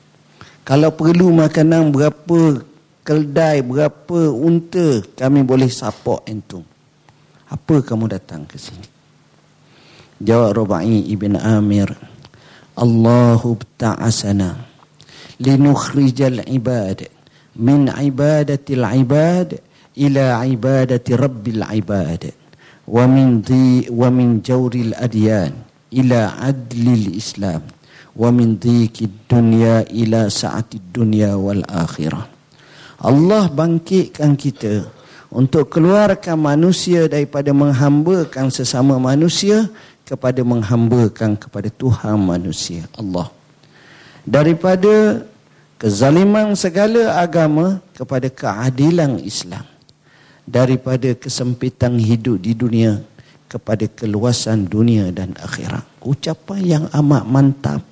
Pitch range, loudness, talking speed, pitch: 115-150 Hz, -15 LUFS, 90 wpm, 130 Hz